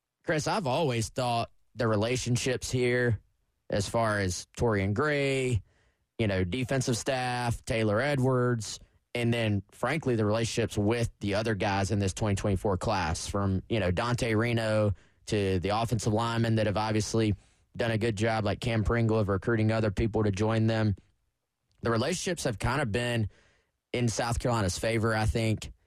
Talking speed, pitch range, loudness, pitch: 160 wpm, 105-120 Hz, -29 LUFS, 110 Hz